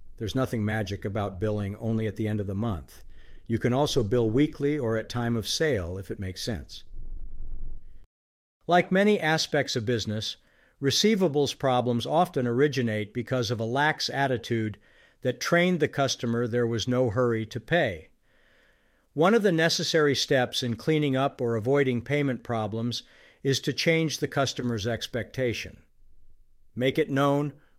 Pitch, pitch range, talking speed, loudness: 120 Hz, 110-140 Hz, 155 wpm, -26 LUFS